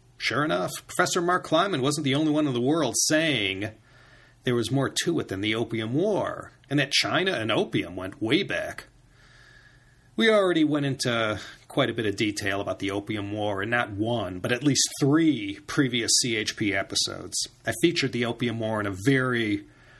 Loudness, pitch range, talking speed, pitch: -25 LUFS, 110-150 Hz, 185 wpm, 120 Hz